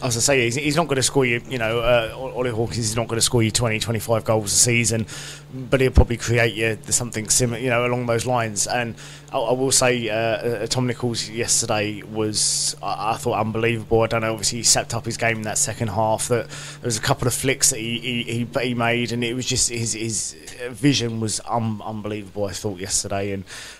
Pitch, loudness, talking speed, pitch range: 115 Hz, -21 LUFS, 215 wpm, 110-125 Hz